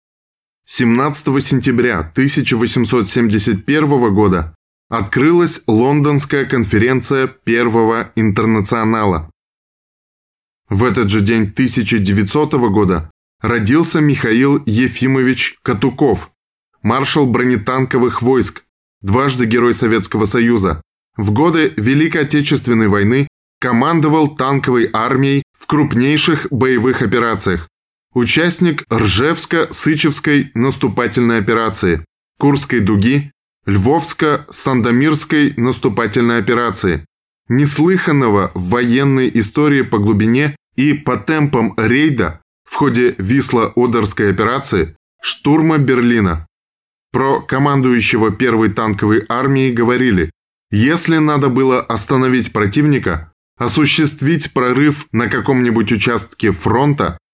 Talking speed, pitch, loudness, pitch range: 85 wpm, 125 Hz, -14 LUFS, 110-140 Hz